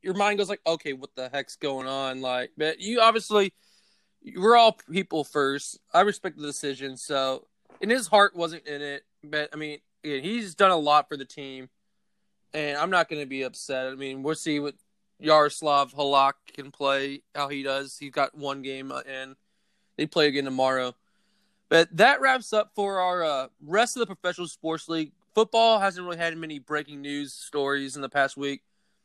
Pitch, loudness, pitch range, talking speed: 150 Hz, -25 LUFS, 140-180 Hz, 190 wpm